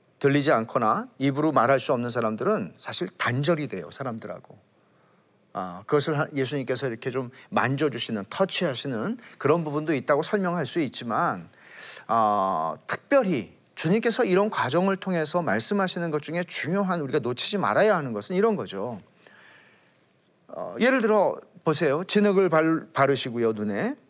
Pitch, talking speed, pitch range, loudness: 155 Hz, 325 characters per minute, 135-185 Hz, -25 LUFS